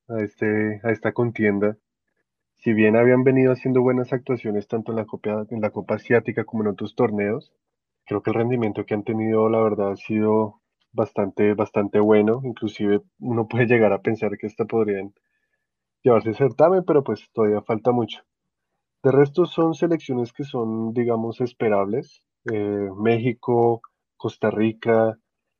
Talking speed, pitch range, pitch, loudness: 155 wpm, 105-120 Hz, 110 Hz, -22 LUFS